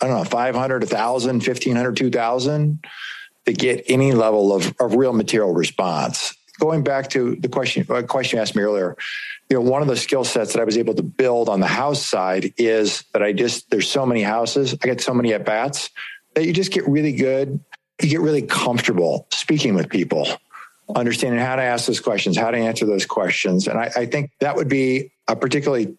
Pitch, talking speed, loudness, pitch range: 130 Hz, 210 wpm, -20 LUFS, 115-150 Hz